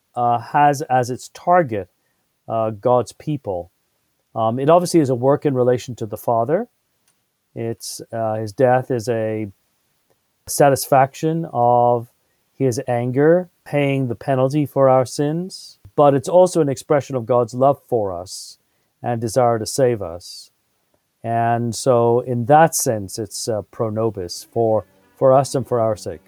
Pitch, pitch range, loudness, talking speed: 125 Hz, 115-145 Hz, -19 LUFS, 150 wpm